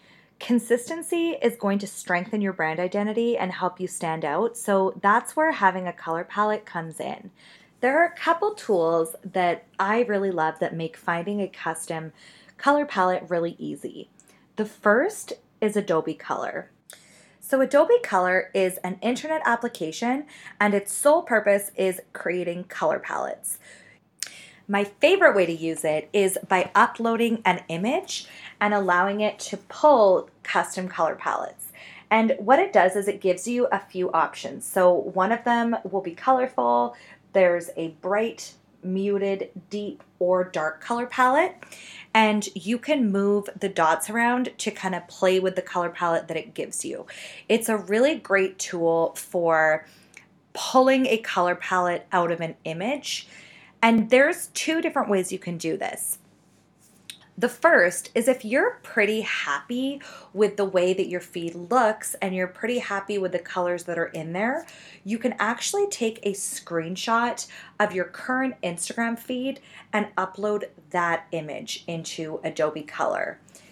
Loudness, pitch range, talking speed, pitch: -24 LUFS, 175-235 Hz, 155 wpm, 200 Hz